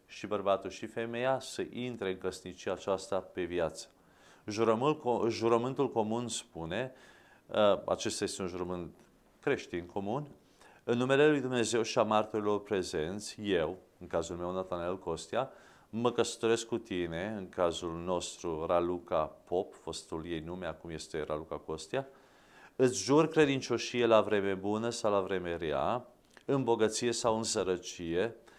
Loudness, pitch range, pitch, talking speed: -33 LUFS, 90-120 Hz, 105 Hz, 135 wpm